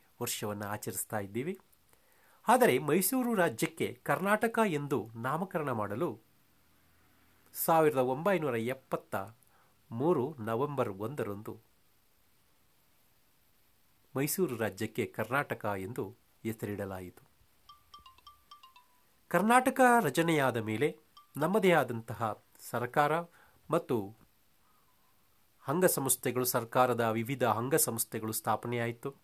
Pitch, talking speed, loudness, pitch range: 125 Hz, 70 wpm, -31 LUFS, 110-170 Hz